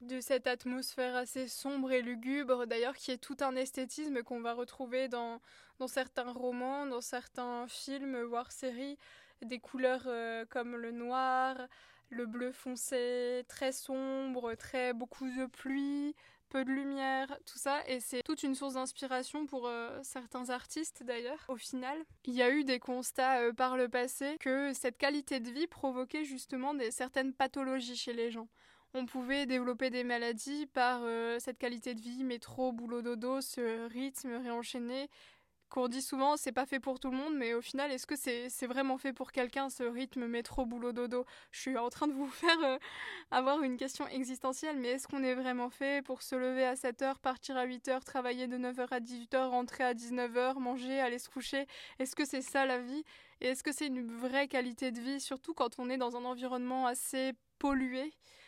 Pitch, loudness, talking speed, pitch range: 255 Hz, -37 LUFS, 195 wpm, 245-270 Hz